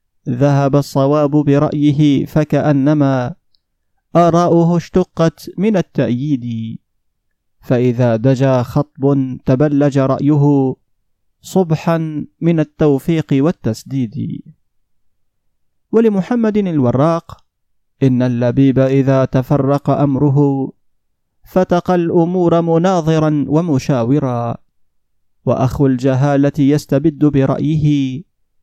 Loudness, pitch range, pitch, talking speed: -14 LUFS, 130-155 Hz, 140 Hz, 65 wpm